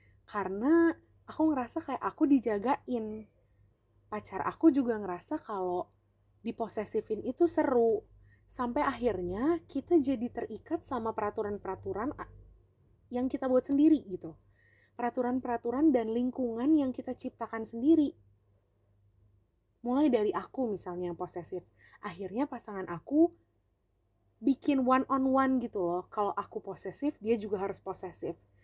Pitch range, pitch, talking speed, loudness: 175-260 Hz, 220 Hz, 115 wpm, -31 LUFS